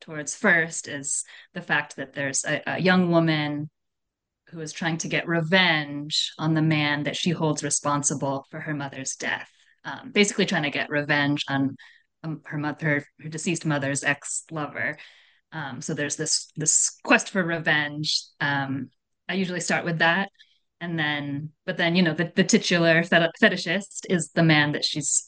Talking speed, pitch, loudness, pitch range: 170 wpm, 155 Hz, -24 LUFS, 145-170 Hz